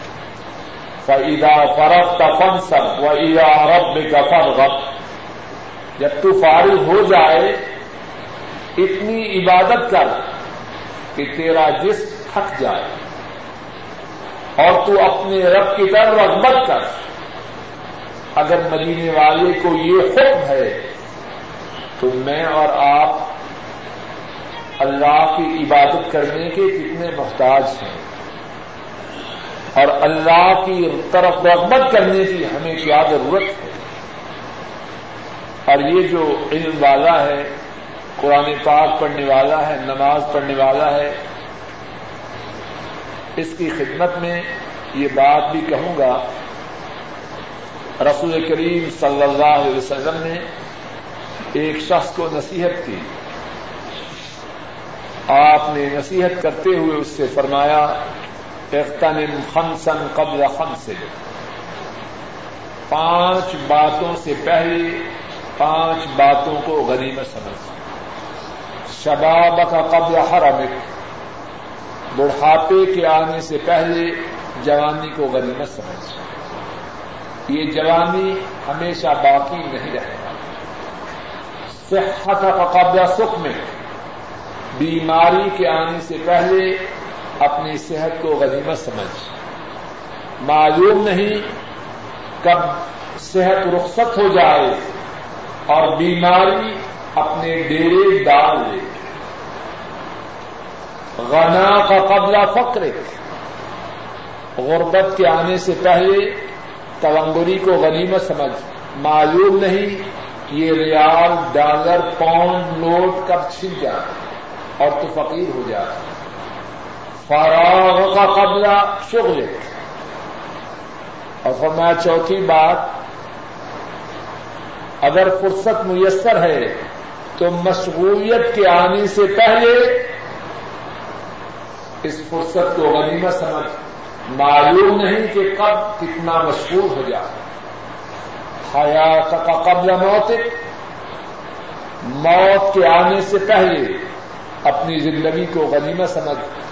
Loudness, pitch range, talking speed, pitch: -15 LUFS, 150-190 Hz, 100 wpm, 165 Hz